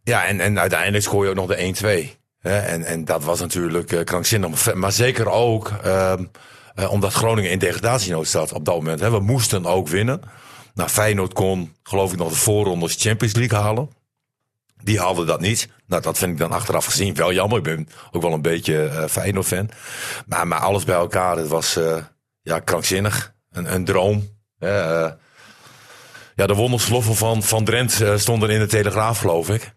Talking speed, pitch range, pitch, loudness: 190 wpm, 85-110 Hz, 100 Hz, -20 LUFS